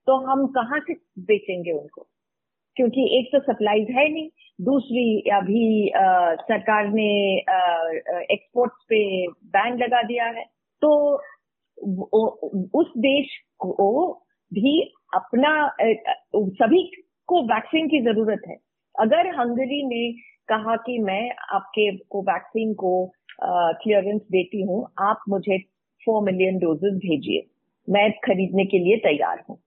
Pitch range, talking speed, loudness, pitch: 195-265 Hz, 120 wpm, -22 LUFS, 220 Hz